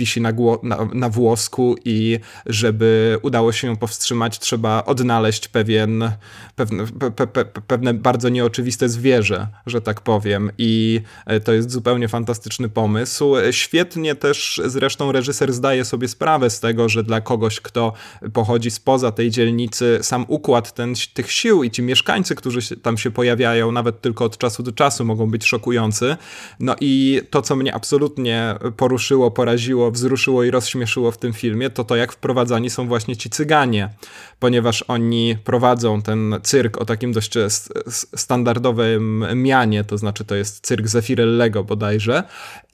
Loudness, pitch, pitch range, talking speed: -18 LUFS, 120 Hz, 115-125 Hz, 150 wpm